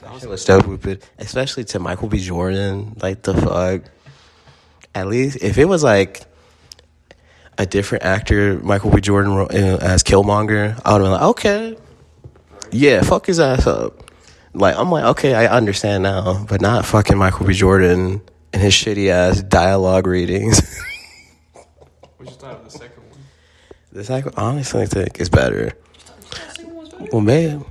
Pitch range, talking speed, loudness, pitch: 95-110 Hz, 155 wpm, -16 LUFS, 100 Hz